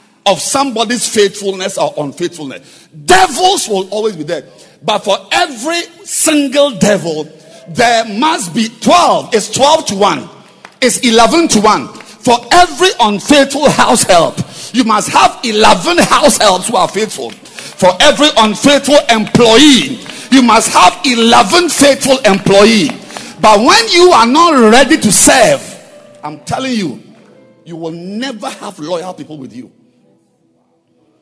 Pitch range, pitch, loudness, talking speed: 200-290 Hz, 235 Hz, -9 LUFS, 135 wpm